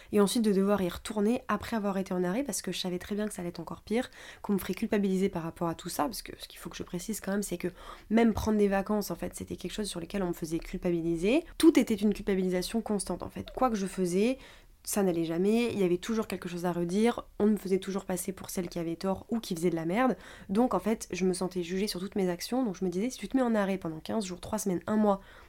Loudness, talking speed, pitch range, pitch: -31 LUFS, 295 wpm, 180-215 Hz, 195 Hz